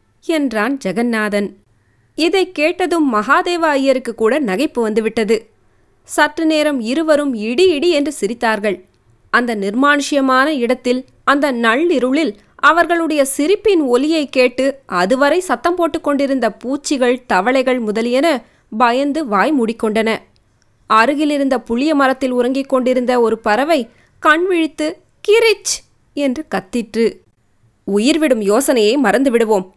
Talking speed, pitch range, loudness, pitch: 95 wpm, 225-300 Hz, -15 LUFS, 260 Hz